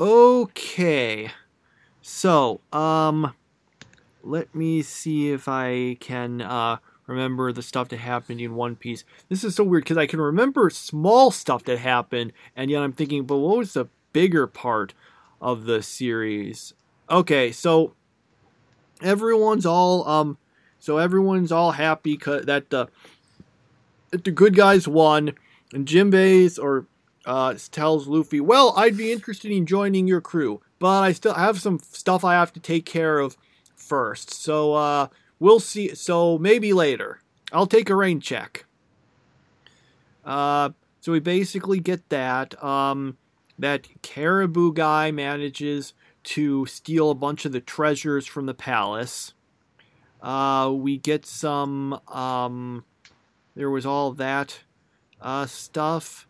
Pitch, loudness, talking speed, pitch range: 150 Hz, -22 LUFS, 140 wpm, 135-180 Hz